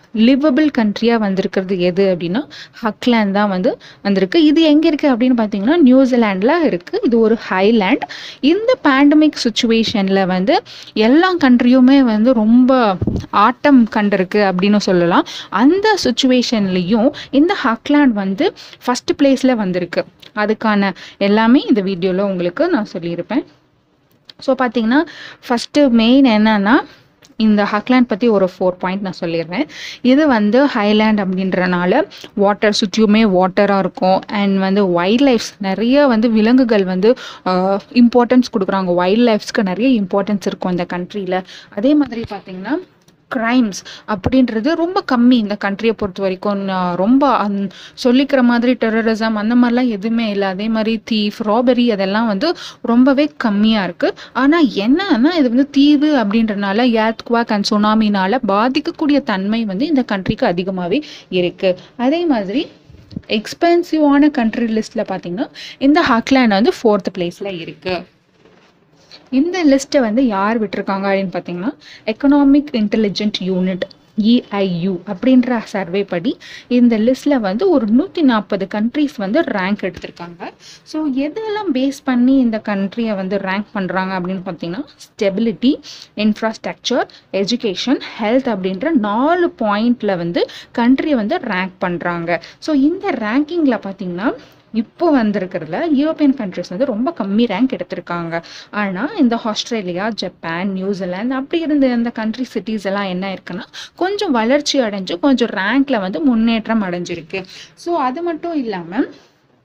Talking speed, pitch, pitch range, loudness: 125 wpm, 225 Hz, 195-270 Hz, -15 LUFS